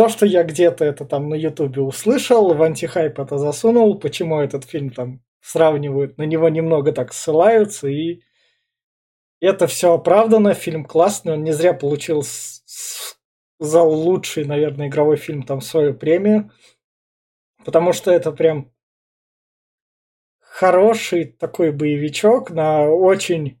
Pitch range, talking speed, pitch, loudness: 145-180 Hz, 130 wpm, 160 Hz, -17 LUFS